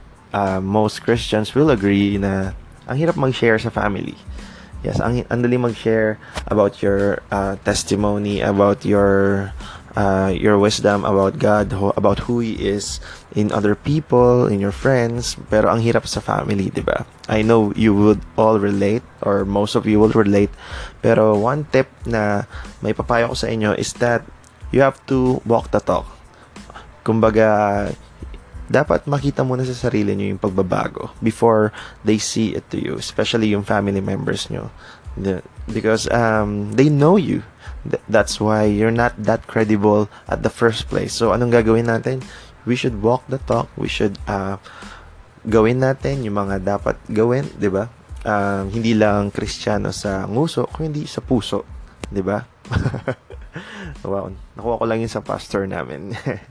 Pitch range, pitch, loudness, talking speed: 100-120 Hz, 110 Hz, -19 LUFS, 155 wpm